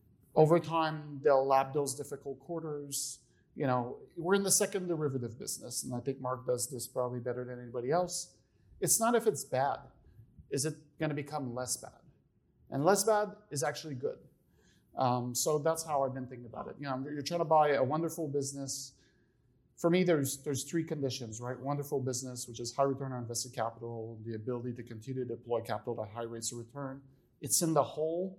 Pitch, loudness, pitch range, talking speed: 135 Hz, -33 LUFS, 125-155 Hz, 200 wpm